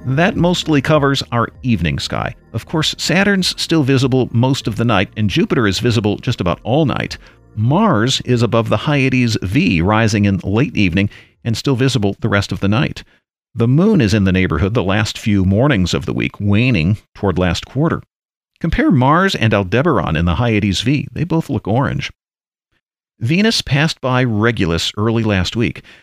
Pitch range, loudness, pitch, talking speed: 100-140 Hz, -16 LUFS, 115 Hz, 180 wpm